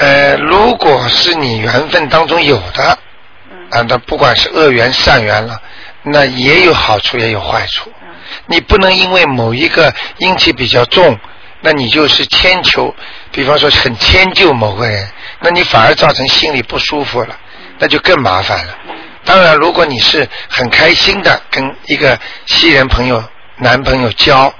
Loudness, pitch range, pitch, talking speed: -8 LUFS, 115-160 Hz, 135 Hz, 235 characters per minute